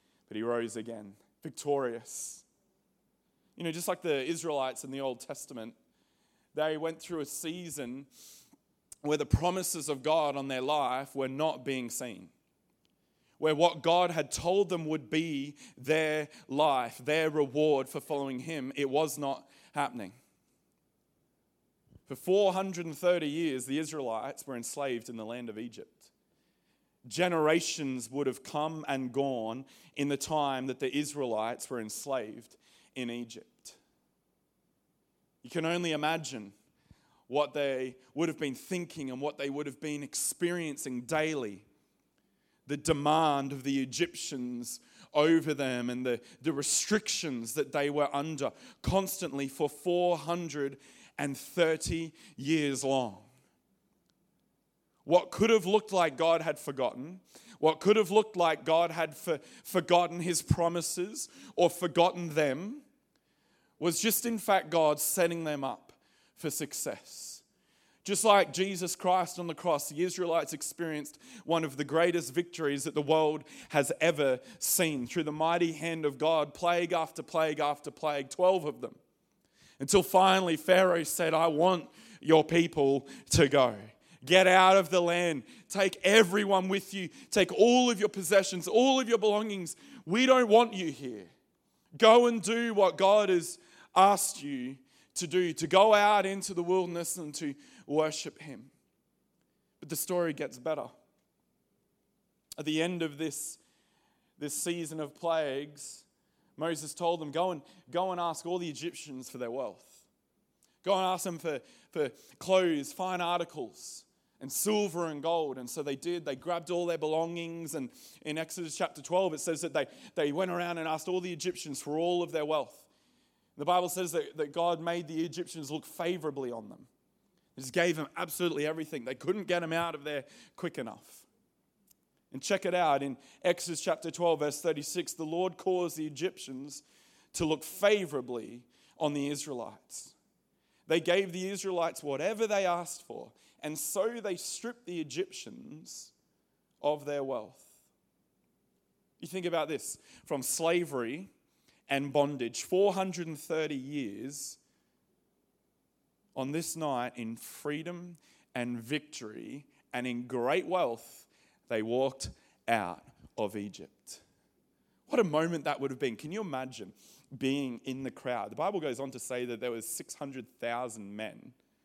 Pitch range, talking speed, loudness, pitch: 140-180 Hz, 150 wpm, -31 LUFS, 160 Hz